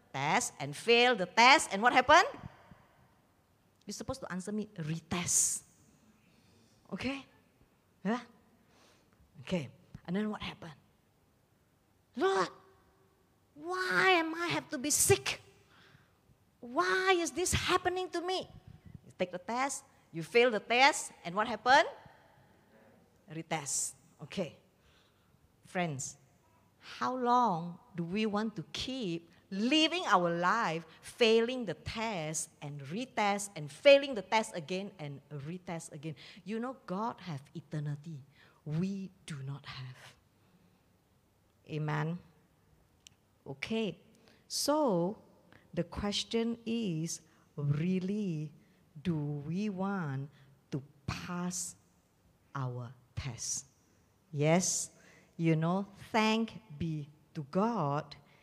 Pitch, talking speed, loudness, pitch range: 175 Hz, 105 wpm, -32 LUFS, 150-225 Hz